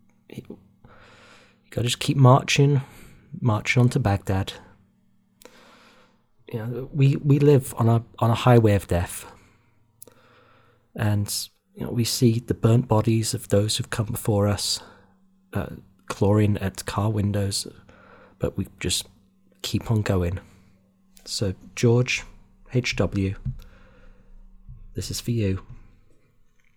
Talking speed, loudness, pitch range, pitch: 120 wpm, -23 LUFS, 100-120 Hz, 110 Hz